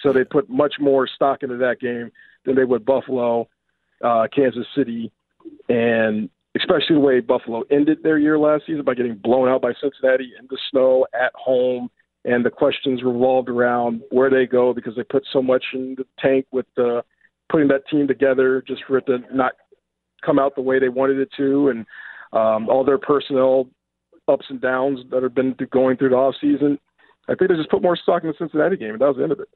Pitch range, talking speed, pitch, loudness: 125-140 Hz, 215 wpm, 130 Hz, -19 LUFS